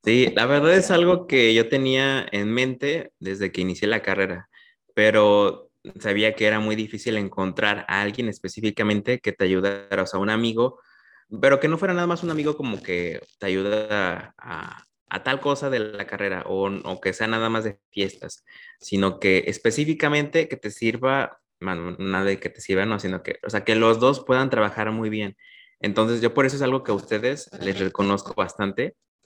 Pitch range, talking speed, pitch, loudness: 100-130 Hz, 195 wpm, 105 Hz, -23 LUFS